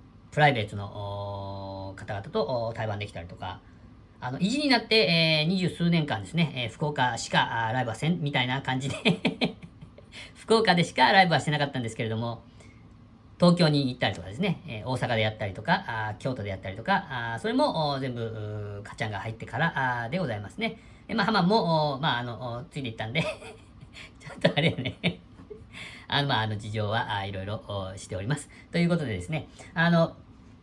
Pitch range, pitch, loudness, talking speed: 110-160 Hz, 125 Hz, -27 LUFS, 375 characters per minute